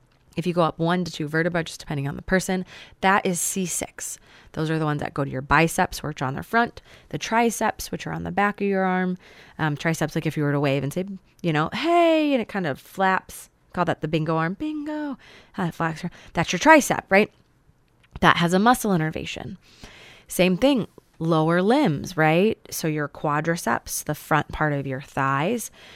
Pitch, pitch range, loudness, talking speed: 170 Hz, 155-195 Hz, -23 LUFS, 200 wpm